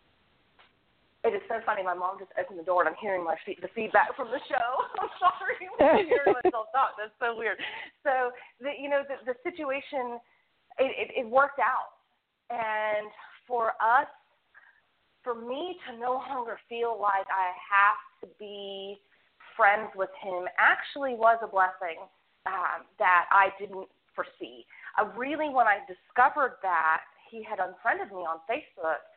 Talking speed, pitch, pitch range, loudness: 165 wpm, 230 Hz, 195-270 Hz, -28 LUFS